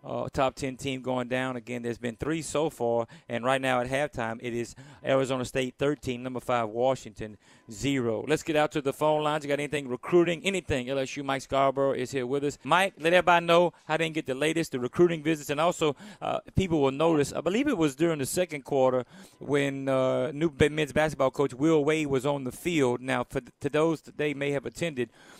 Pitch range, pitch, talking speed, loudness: 130-155 Hz, 140 Hz, 220 wpm, -28 LUFS